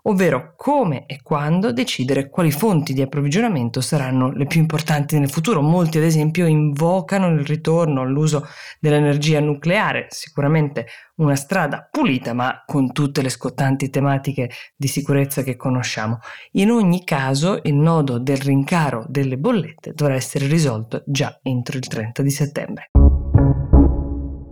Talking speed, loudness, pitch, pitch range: 135 wpm, -19 LUFS, 145 Hz, 135-160 Hz